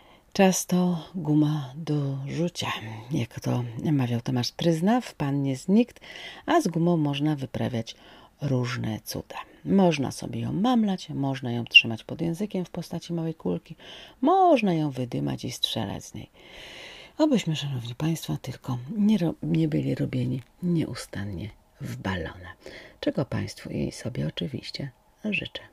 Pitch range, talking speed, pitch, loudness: 125-175 Hz, 135 wpm, 150 Hz, -26 LUFS